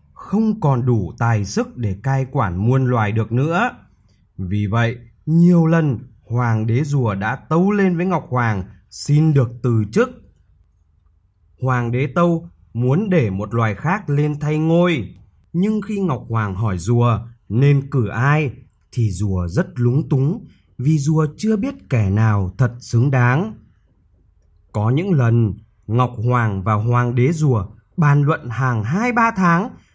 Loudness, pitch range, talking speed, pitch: -18 LUFS, 105-150 Hz, 155 wpm, 120 Hz